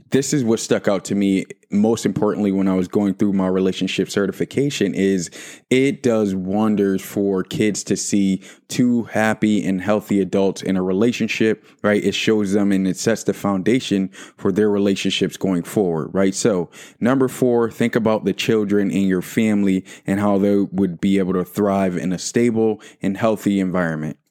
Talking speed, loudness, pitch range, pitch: 180 wpm, -19 LUFS, 95-110 Hz, 100 Hz